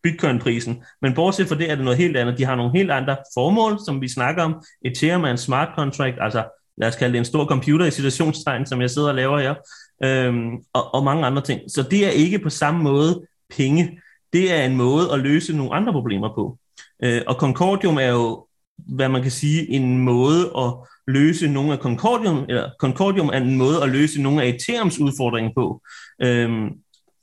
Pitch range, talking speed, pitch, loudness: 125-160 Hz, 205 wpm, 140 Hz, -20 LUFS